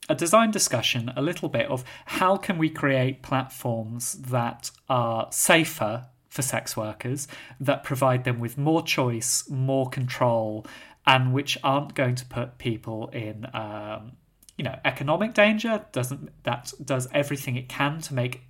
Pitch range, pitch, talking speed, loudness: 120-145 Hz, 130 Hz, 150 wpm, -25 LUFS